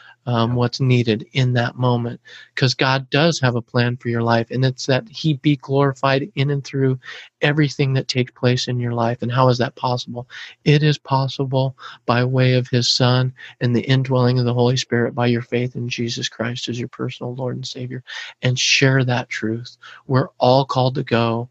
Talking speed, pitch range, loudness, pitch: 200 wpm, 120-135 Hz, -19 LUFS, 125 Hz